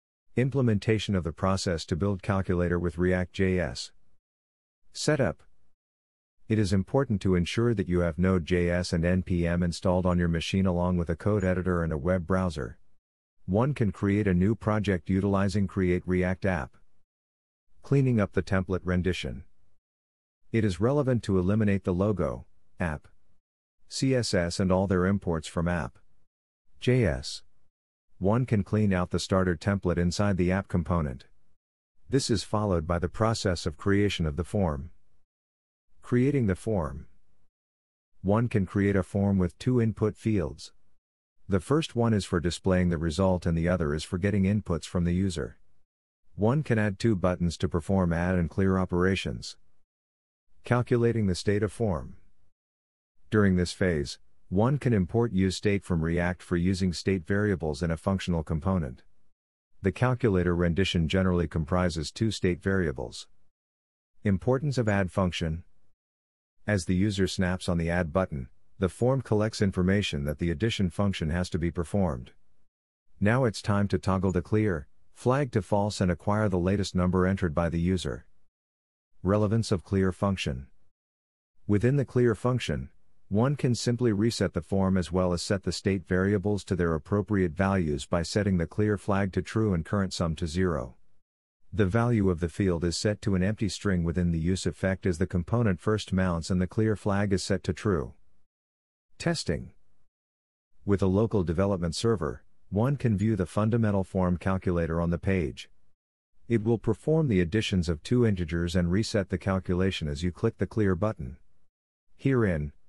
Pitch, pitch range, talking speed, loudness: 95 Hz, 85-105 Hz, 160 wpm, -28 LUFS